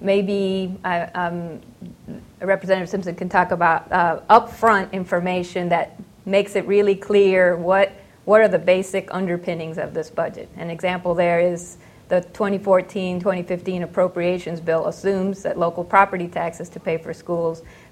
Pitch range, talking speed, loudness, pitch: 175-195 Hz, 135 wpm, -20 LUFS, 180 Hz